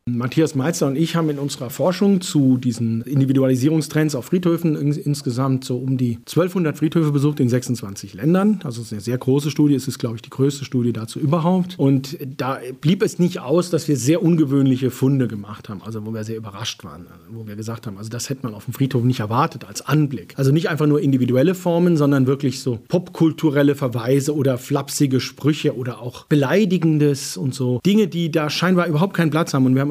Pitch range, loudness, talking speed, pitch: 125-160 Hz, -19 LUFS, 210 wpm, 140 Hz